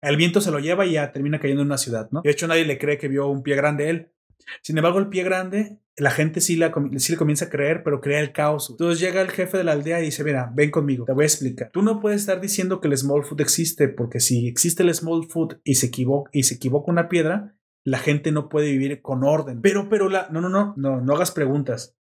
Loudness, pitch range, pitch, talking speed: -21 LUFS, 140-170 Hz, 150 Hz, 270 wpm